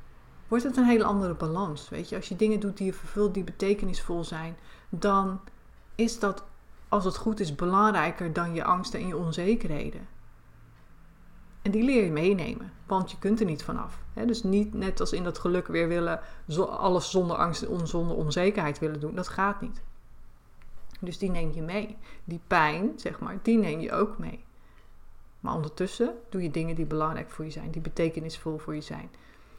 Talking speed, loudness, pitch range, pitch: 185 wpm, -29 LUFS, 165-205 Hz, 185 Hz